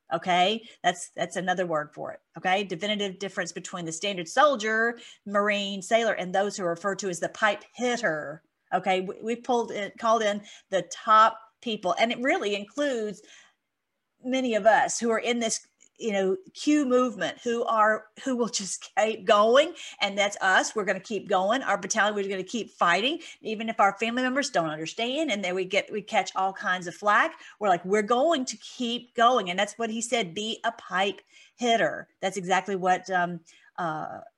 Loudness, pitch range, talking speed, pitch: -26 LUFS, 190-235 Hz, 195 wpm, 210 Hz